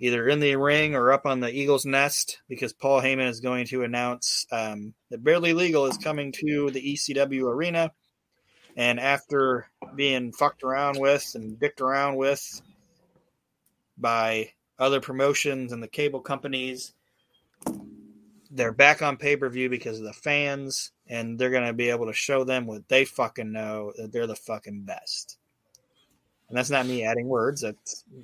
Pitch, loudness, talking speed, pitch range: 130 Hz, -25 LUFS, 170 wpm, 120-140 Hz